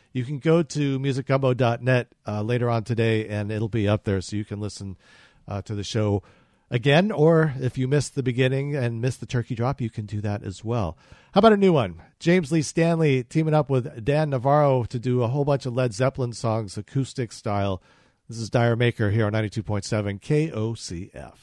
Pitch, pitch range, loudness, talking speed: 120 Hz, 105-140 Hz, -24 LUFS, 200 wpm